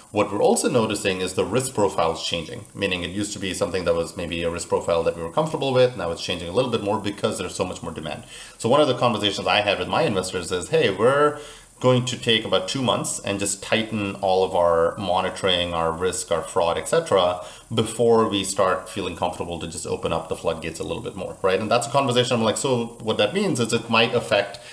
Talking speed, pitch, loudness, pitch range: 245 wpm, 110 Hz, -22 LUFS, 95-125 Hz